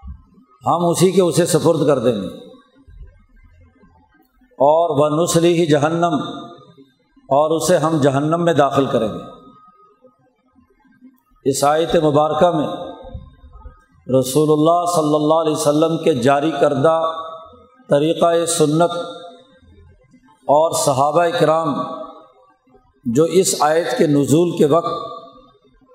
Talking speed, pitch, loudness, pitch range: 105 wpm, 160 Hz, -16 LUFS, 145-175 Hz